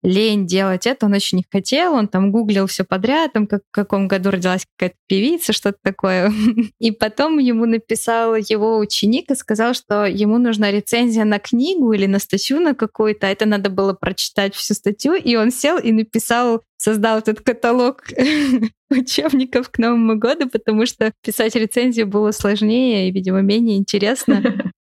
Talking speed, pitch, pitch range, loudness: 165 wpm, 220 Hz, 200-240 Hz, -17 LUFS